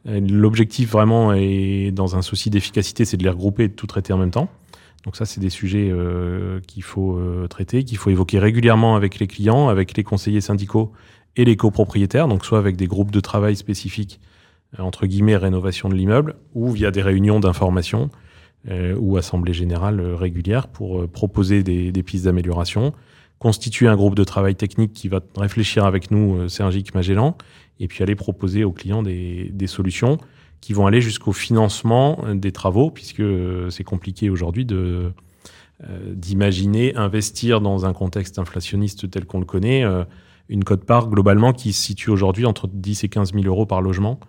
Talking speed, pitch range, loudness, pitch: 185 wpm, 95-110 Hz, -19 LUFS, 100 Hz